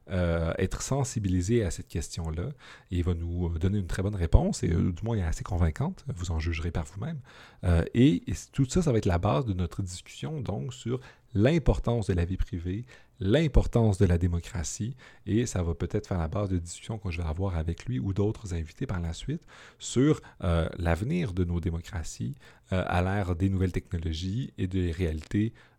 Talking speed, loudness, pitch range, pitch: 200 wpm, -29 LUFS, 85-115 Hz, 95 Hz